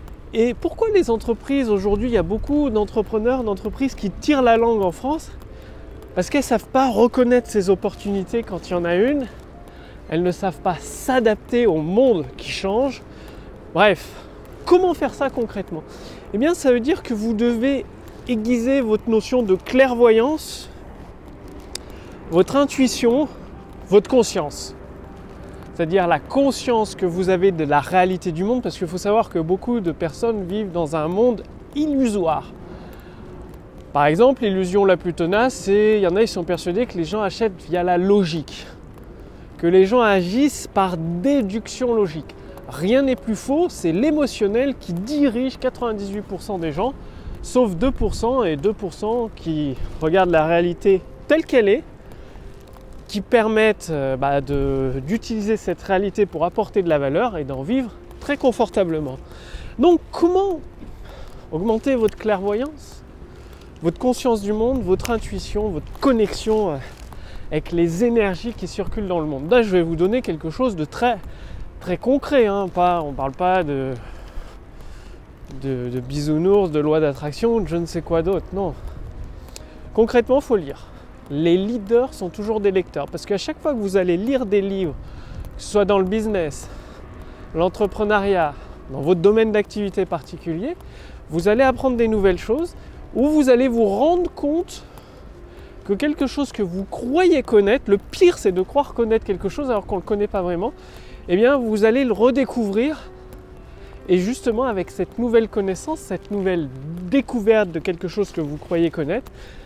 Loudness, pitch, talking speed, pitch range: -20 LUFS, 205 Hz, 160 wpm, 175-245 Hz